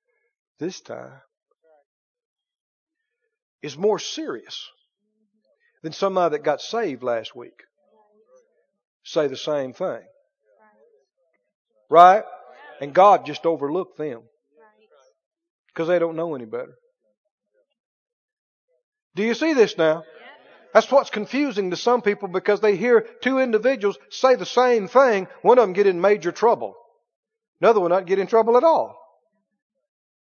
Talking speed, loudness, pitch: 125 wpm, -20 LUFS, 220 Hz